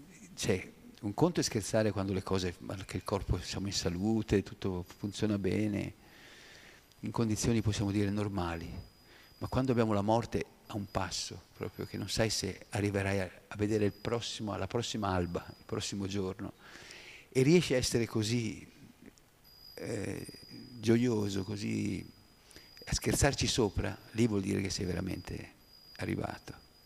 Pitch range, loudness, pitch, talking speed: 95-110 Hz, -34 LUFS, 105 Hz, 140 wpm